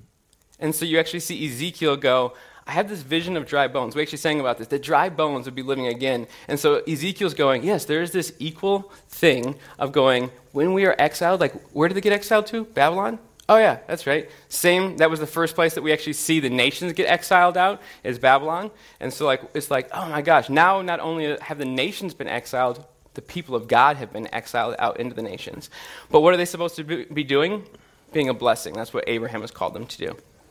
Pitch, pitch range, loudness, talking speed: 160 Hz, 140-180 Hz, -22 LUFS, 230 wpm